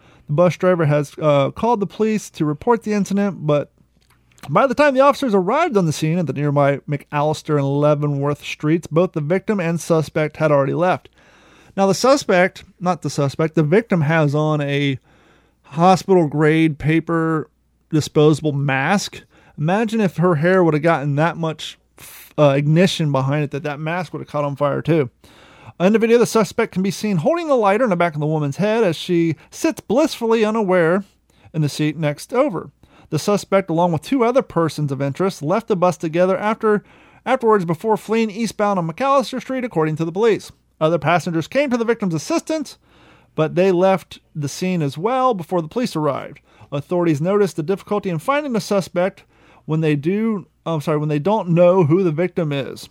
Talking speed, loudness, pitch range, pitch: 190 wpm, -18 LUFS, 150-205 Hz, 170 Hz